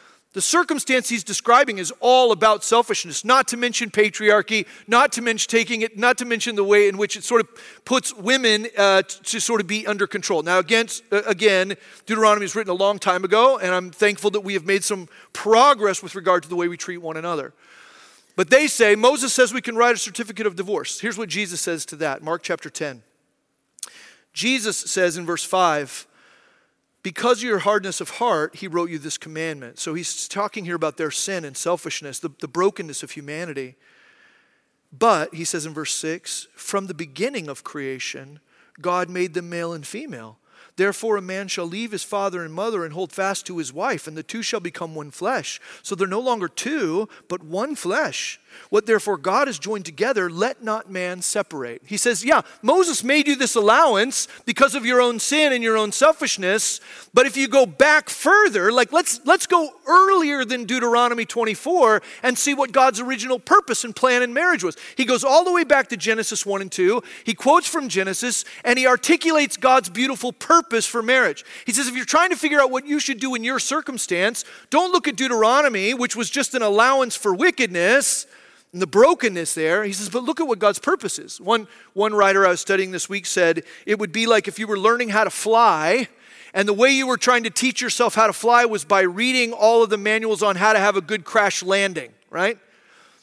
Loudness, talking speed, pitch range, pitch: -19 LUFS, 210 wpm, 190-255 Hz, 215 Hz